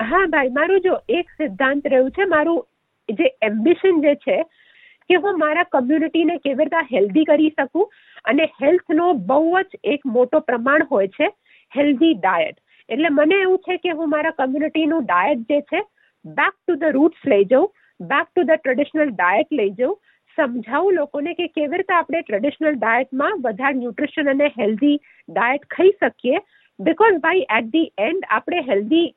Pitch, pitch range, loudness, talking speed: 310 Hz, 275-340 Hz, -19 LUFS, 165 wpm